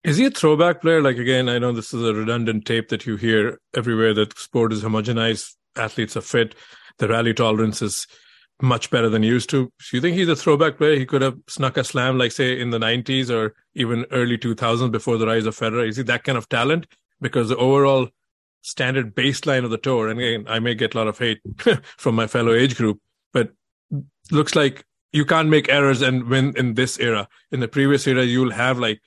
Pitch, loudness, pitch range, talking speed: 125 Hz, -20 LUFS, 115-135 Hz, 225 wpm